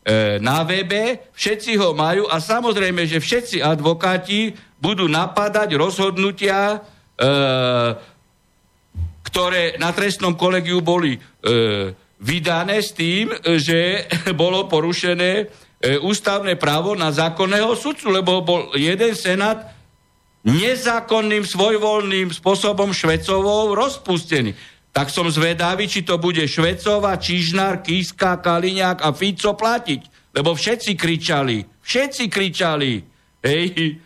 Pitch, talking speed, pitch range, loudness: 180 Hz, 100 wpm, 160-205 Hz, -19 LUFS